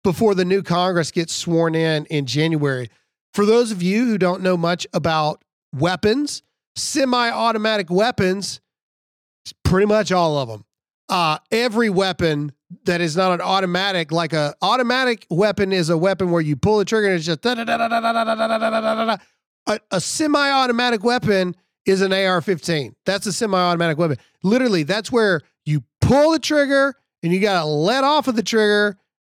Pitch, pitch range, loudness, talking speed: 195 Hz, 170-225 Hz, -19 LUFS, 165 wpm